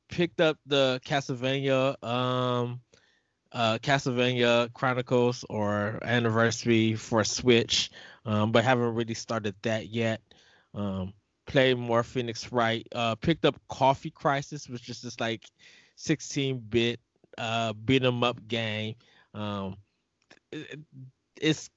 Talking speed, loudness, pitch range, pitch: 115 wpm, -28 LUFS, 115-130 Hz, 120 Hz